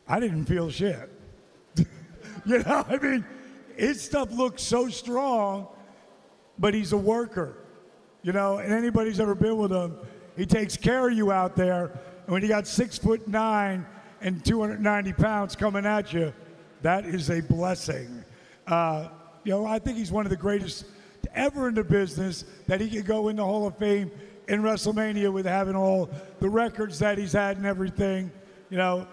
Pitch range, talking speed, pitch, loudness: 180-215 Hz, 175 wpm, 200 Hz, -27 LUFS